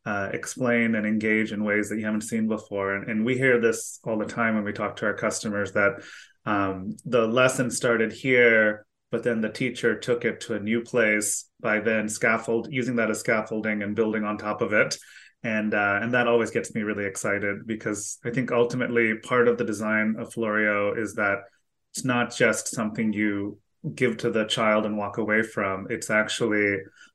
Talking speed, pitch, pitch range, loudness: 200 wpm, 110 Hz, 105-120 Hz, -25 LUFS